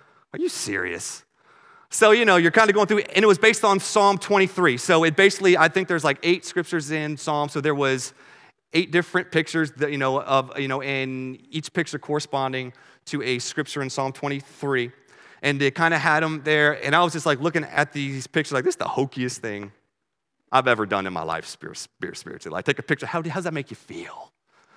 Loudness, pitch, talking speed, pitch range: -22 LUFS, 150 Hz, 225 wpm, 135-175 Hz